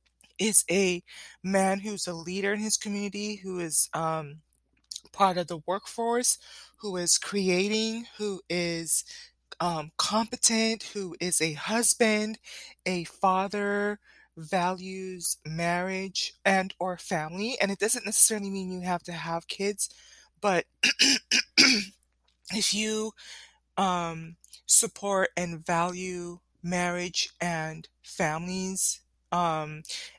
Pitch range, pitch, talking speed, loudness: 175-205 Hz, 185 Hz, 110 wpm, -27 LUFS